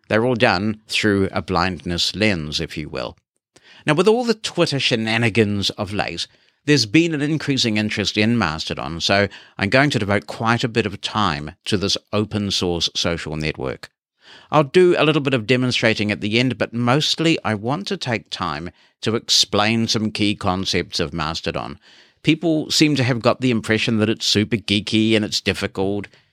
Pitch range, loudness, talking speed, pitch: 100-130 Hz, -19 LUFS, 180 wpm, 110 Hz